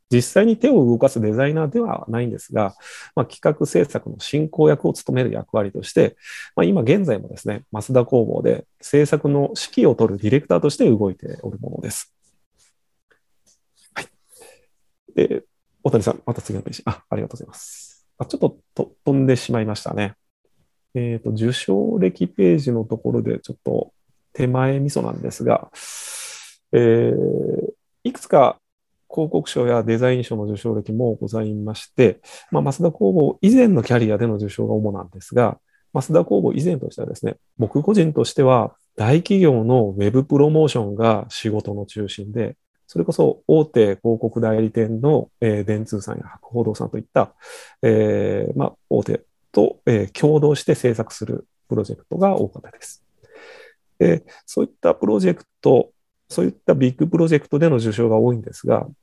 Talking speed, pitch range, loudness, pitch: 335 characters per minute, 110-150 Hz, -19 LUFS, 120 Hz